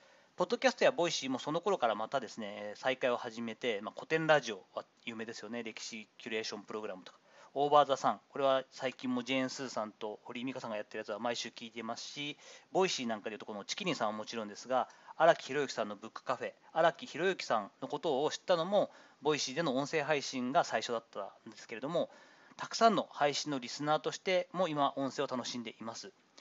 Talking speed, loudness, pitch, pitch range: 475 characters per minute, -35 LUFS, 135 Hz, 120-170 Hz